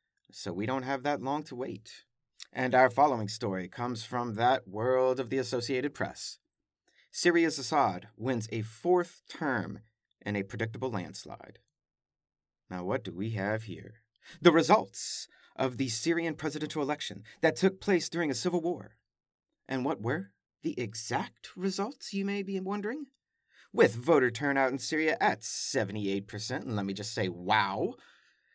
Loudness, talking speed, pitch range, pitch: -31 LUFS, 155 wpm, 110-160 Hz, 130 Hz